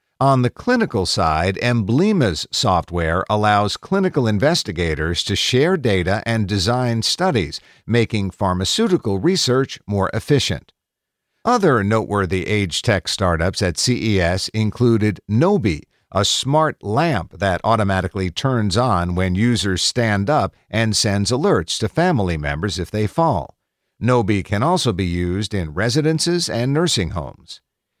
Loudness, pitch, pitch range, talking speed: -18 LUFS, 105 Hz, 95-125 Hz, 125 wpm